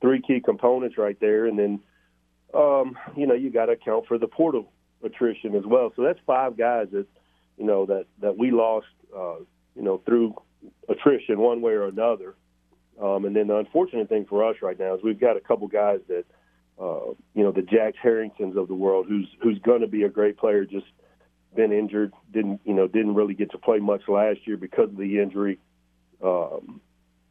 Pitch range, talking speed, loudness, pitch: 100-120 Hz, 205 wpm, -24 LUFS, 105 Hz